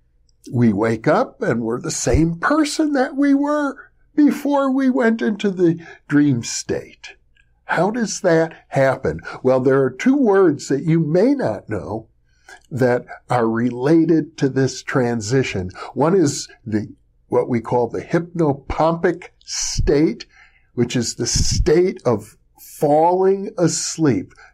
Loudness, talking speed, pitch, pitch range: -19 LUFS, 130 wpm, 150 Hz, 120-190 Hz